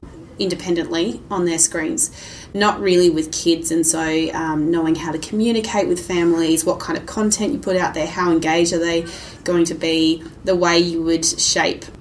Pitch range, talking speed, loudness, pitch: 160-180 Hz, 185 wpm, -18 LUFS, 170 Hz